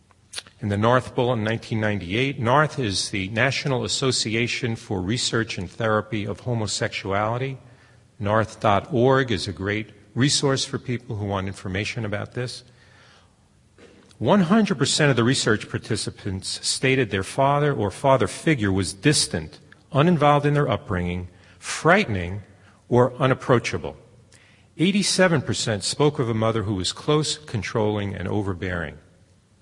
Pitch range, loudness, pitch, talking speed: 100-130 Hz, -23 LUFS, 110 Hz, 120 wpm